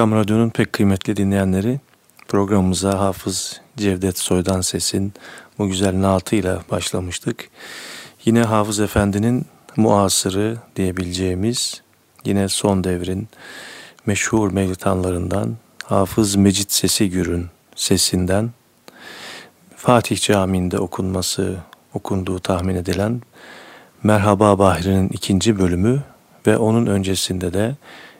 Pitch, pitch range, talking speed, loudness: 100 Hz, 95-110 Hz, 90 wpm, -19 LUFS